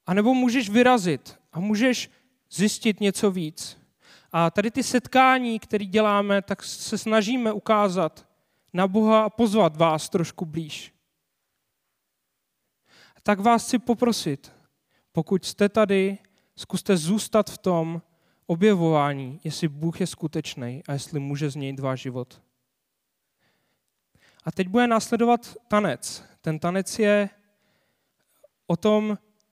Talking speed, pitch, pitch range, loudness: 120 wpm, 200 Hz, 165-220 Hz, -24 LUFS